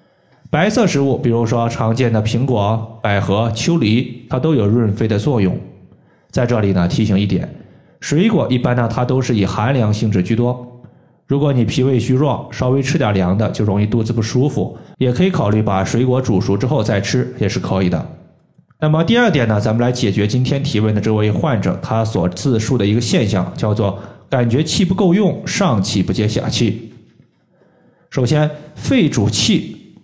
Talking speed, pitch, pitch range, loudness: 270 characters per minute, 120 Hz, 105-135 Hz, -16 LUFS